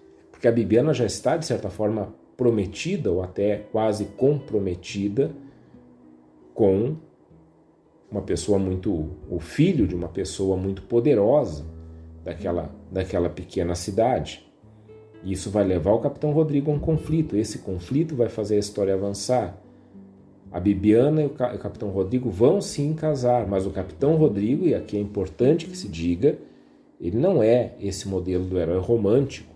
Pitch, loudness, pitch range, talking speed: 105 Hz, -24 LUFS, 95-125 Hz, 150 wpm